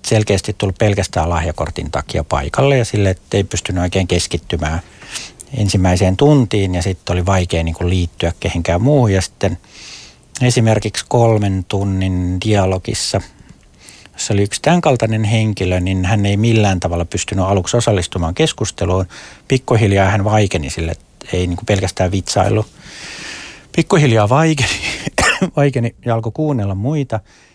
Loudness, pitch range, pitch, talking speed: -16 LUFS, 90-115 Hz, 100 Hz, 125 wpm